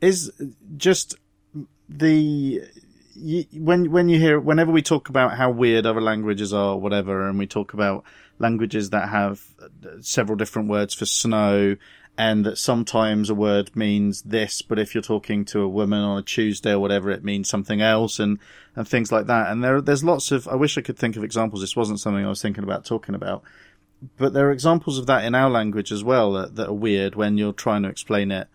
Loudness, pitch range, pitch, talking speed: -21 LUFS, 100-130 Hz, 110 Hz, 210 wpm